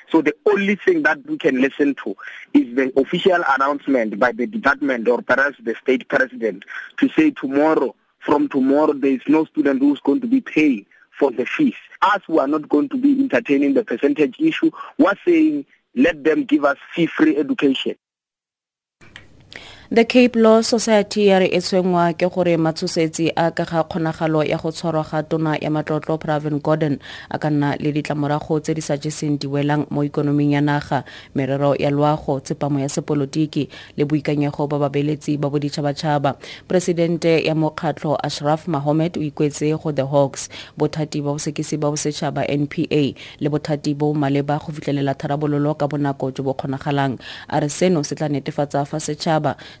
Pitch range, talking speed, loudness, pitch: 145-165 Hz, 175 wpm, -19 LUFS, 150 Hz